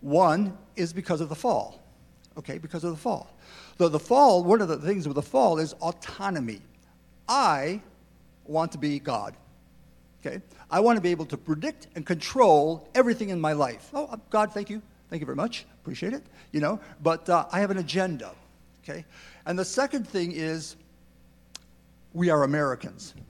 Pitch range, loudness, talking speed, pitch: 145-195 Hz, -26 LUFS, 180 wpm, 165 Hz